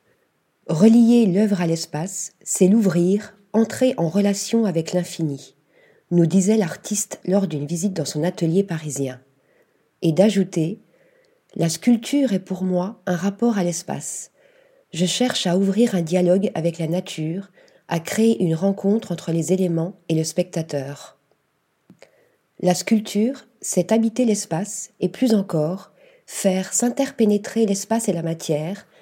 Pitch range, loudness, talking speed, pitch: 170-220 Hz, -21 LUFS, 135 wpm, 190 Hz